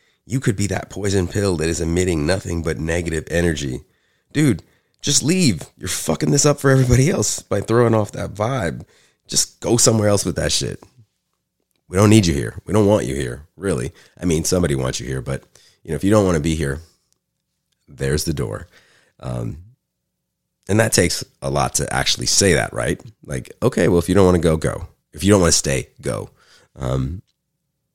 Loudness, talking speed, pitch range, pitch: -19 LUFS, 200 wpm, 80-110 Hz, 90 Hz